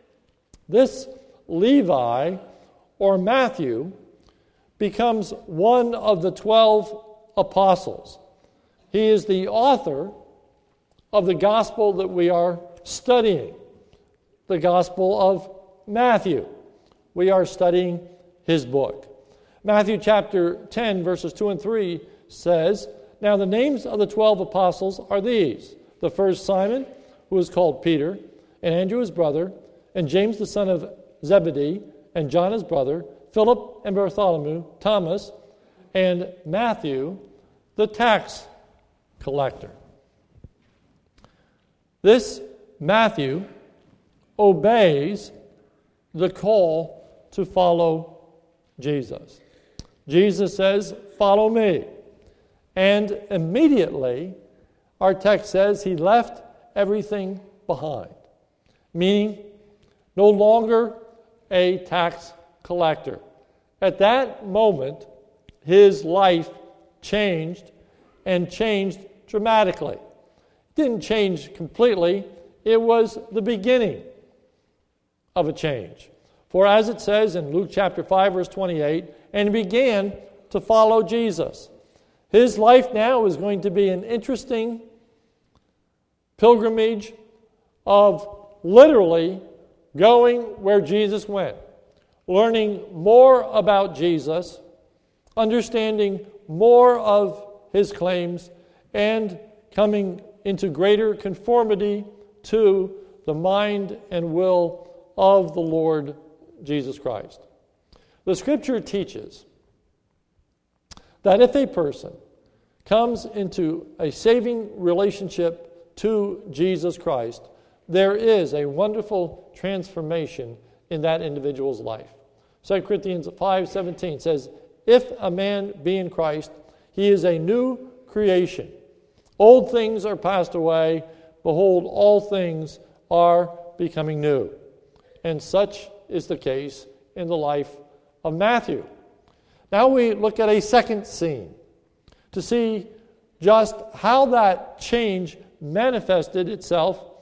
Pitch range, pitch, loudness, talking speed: 175-215 Hz, 195 Hz, -20 LUFS, 105 wpm